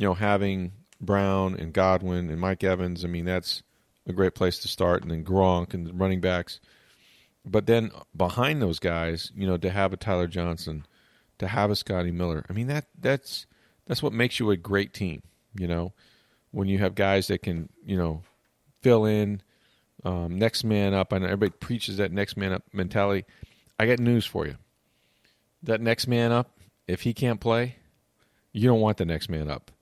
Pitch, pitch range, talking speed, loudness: 95 Hz, 90-110 Hz, 195 wpm, -26 LUFS